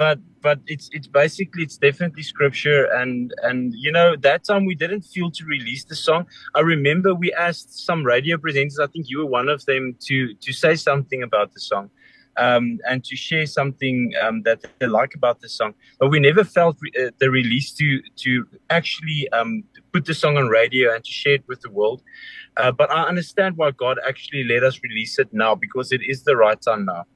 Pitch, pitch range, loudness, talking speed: 140 Hz, 130-165 Hz, -20 LUFS, 210 wpm